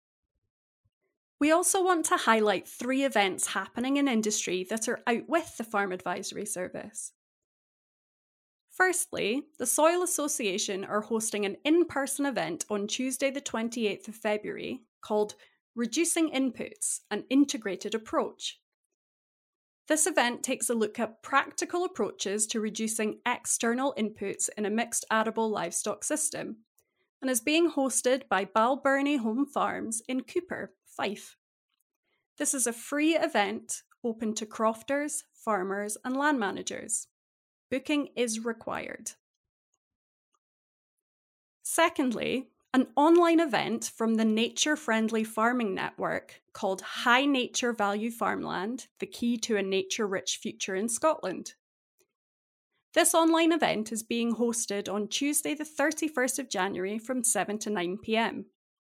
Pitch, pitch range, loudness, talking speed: 240 Hz, 215-295 Hz, -29 LUFS, 125 wpm